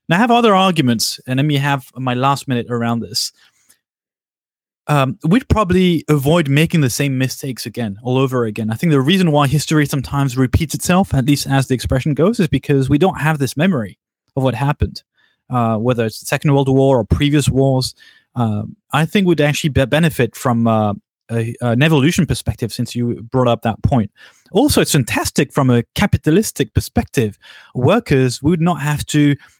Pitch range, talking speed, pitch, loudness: 120-150 Hz, 185 wpm, 135 Hz, -16 LUFS